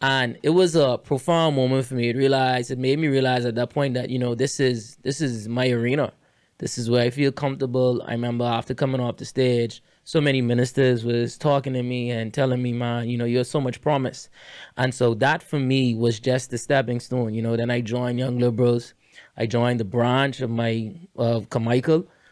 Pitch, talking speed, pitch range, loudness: 125 Hz, 220 wpm, 120-135 Hz, -23 LUFS